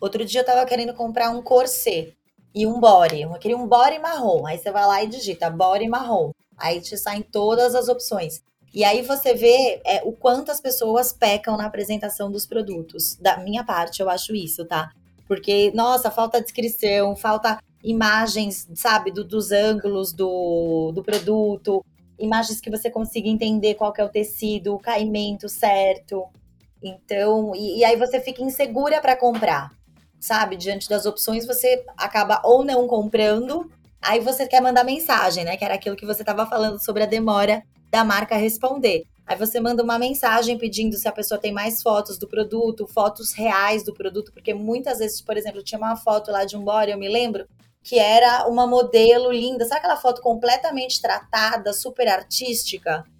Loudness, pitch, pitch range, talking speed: -21 LUFS, 215 Hz, 205-240 Hz, 180 wpm